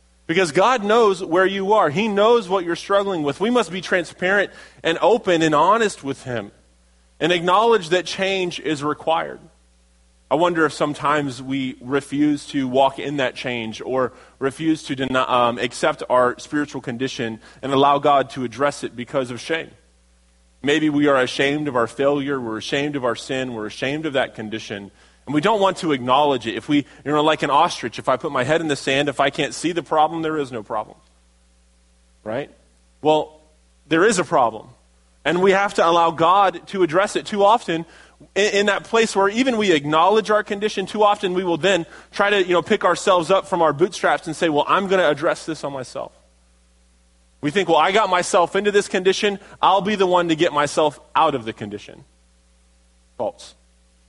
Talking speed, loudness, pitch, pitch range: 200 wpm, -20 LUFS, 150 Hz, 120-185 Hz